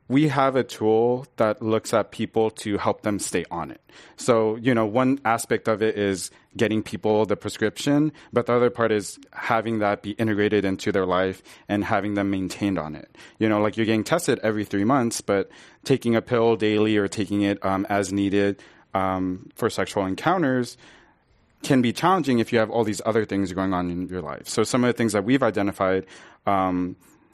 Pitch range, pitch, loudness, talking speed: 100-115 Hz, 110 Hz, -23 LUFS, 200 wpm